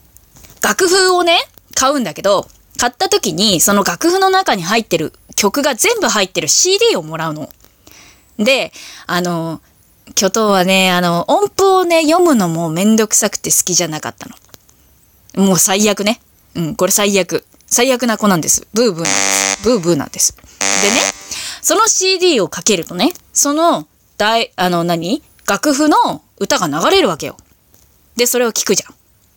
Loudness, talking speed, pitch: -13 LUFS, 300 characters per minute, 210 Hz